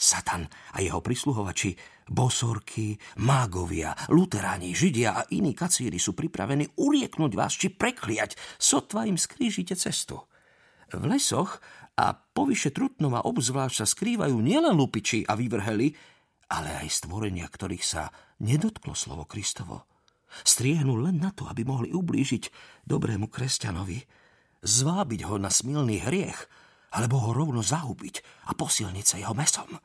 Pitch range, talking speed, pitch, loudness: 105-155 Hz, 130 wpm, 125 Hz, -27 LUFS